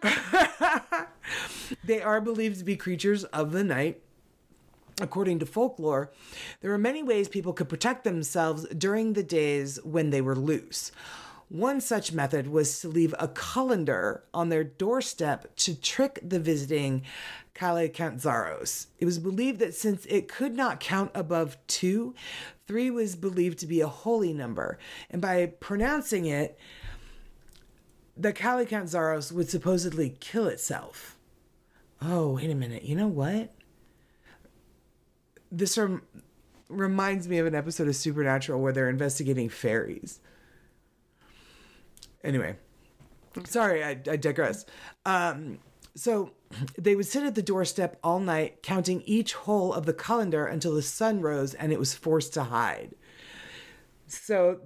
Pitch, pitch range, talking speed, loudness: 175 Hz, 155-210 Hz, 135 wpm, -29 LUFS